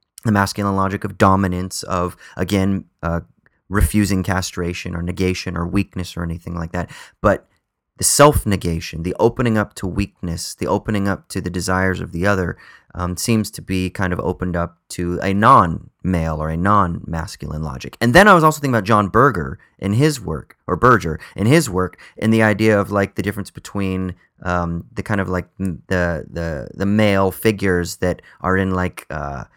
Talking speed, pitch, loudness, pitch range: 180 wpm, 95 Hz, -19 LUFS, 85-100 Hz